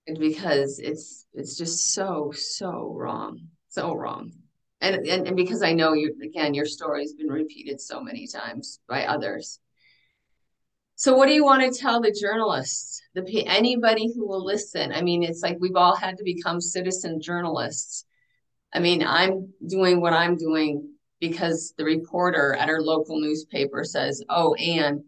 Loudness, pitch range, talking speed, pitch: -24 LUFS, 155-190 Hz, 165 wpm, 170 Hz